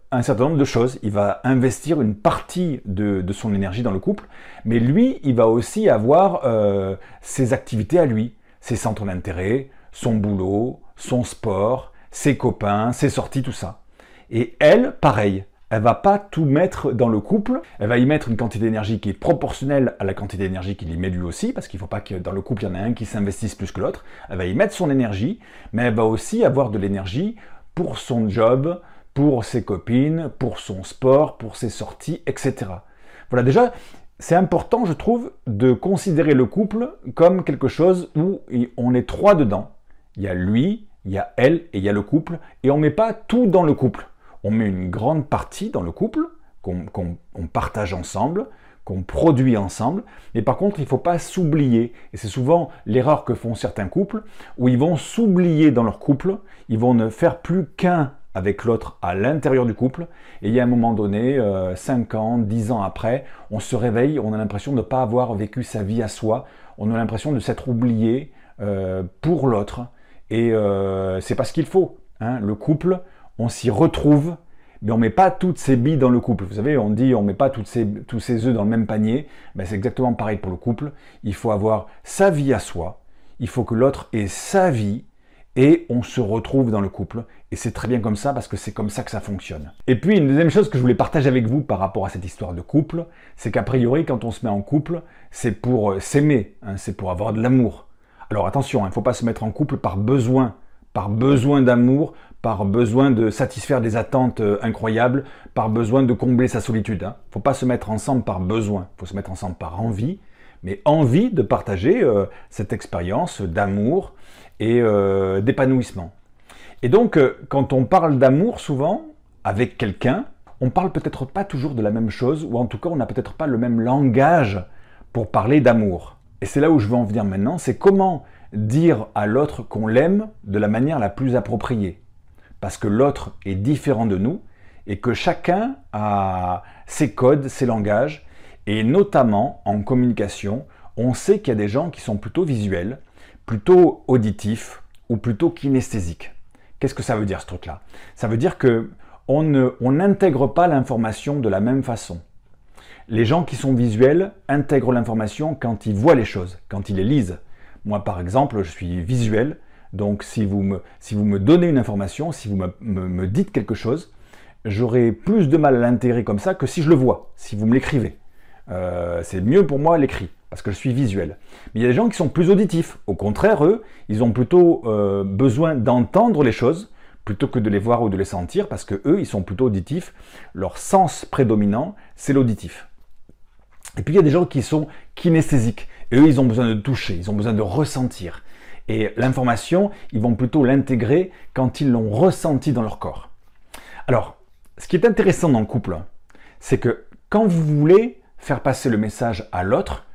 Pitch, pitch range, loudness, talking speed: 120 Hz, 105-140 Hz, -20 LUFS, 205 wpm